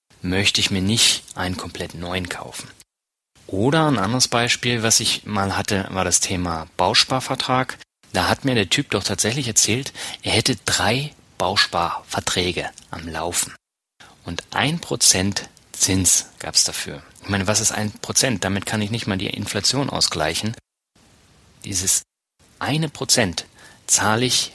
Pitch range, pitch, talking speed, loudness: 95-125 Hz, 105 Hz, 145 wpm, -19 LUFS